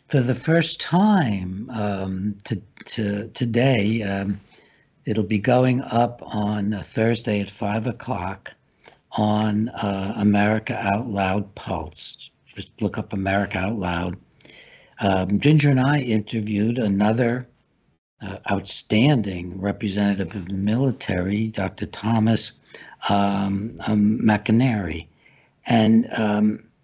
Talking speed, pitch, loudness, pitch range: 110 wpm, 105 Hz, -22 LUFS, 100-115 Hz